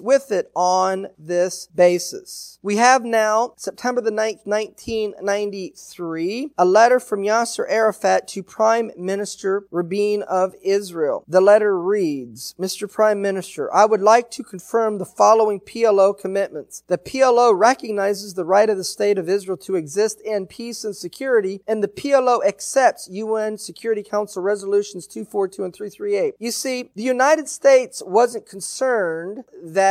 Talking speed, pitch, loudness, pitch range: 145 wpm, 205 Hz, -19 LUFS, 190-230 Hz